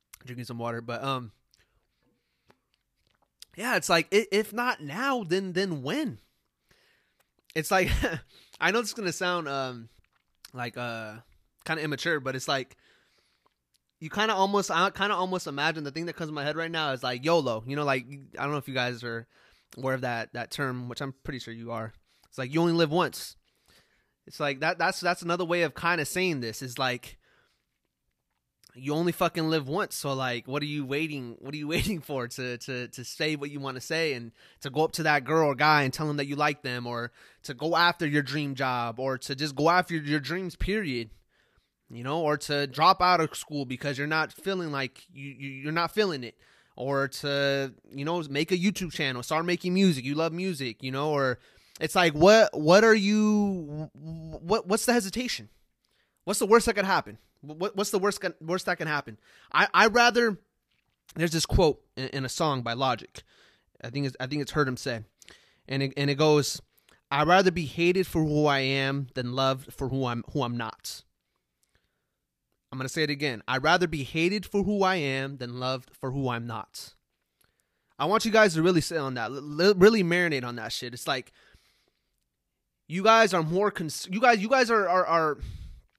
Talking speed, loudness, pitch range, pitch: 210 wpm, -27 LUFS, 130-175 Hz, 150 Hz